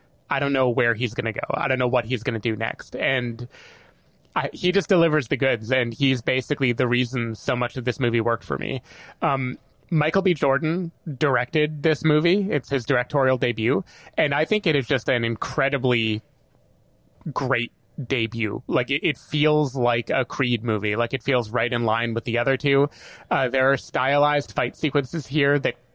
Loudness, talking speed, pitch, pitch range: -23 LUFS, 195 wpm, 130 Hz, 120-145 Hz